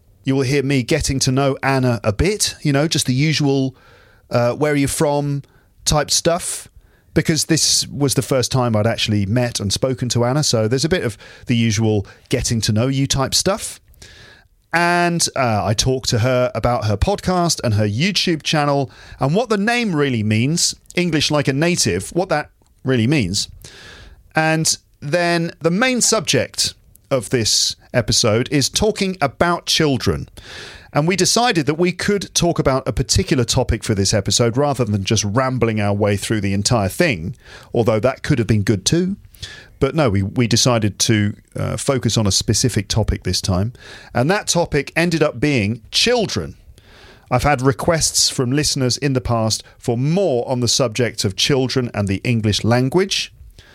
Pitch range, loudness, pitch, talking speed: 110-150 Hz, -18 LUFS, 130 Hz, 175 wpm